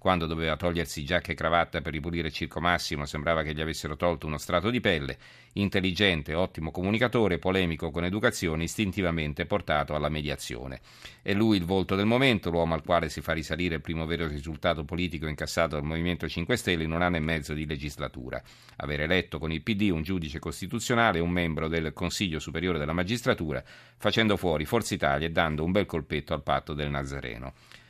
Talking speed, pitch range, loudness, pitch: 185 wpm, 80-95 Hz, -28 LUFS, 85 Hz